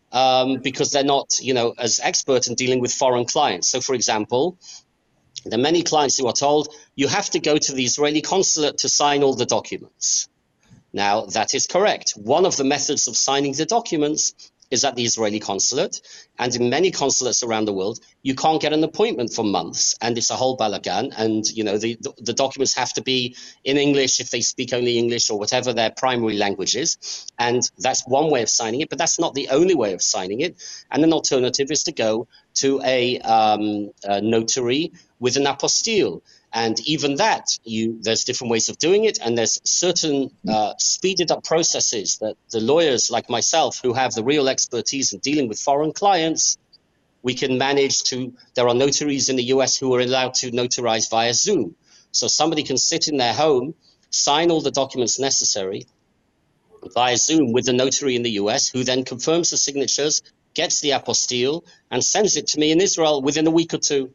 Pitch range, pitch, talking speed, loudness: 120-145 Hz, 130 Hz, 200 wpm, -20 LUFS